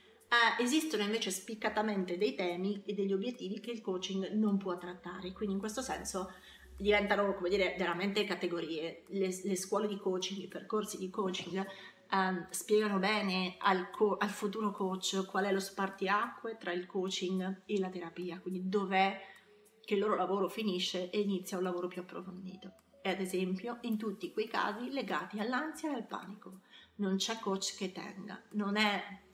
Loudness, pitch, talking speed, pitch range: -35 LUFS, 195 Hz, 170 wpm, 185-210 Hz